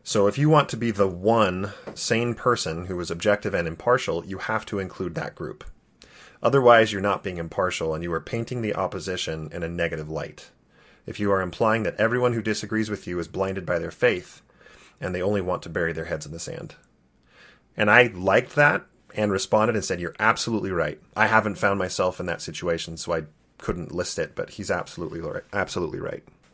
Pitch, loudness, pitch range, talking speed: 100 Hz, -24 LUFS, 90-115 Hz, 205 wpm